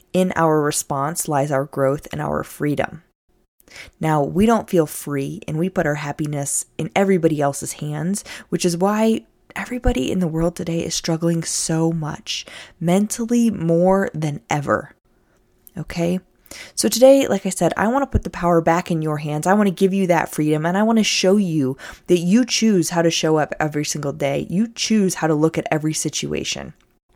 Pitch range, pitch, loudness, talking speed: 150-190 Hz, 170 Hz, -20 LUFS, 185 wpm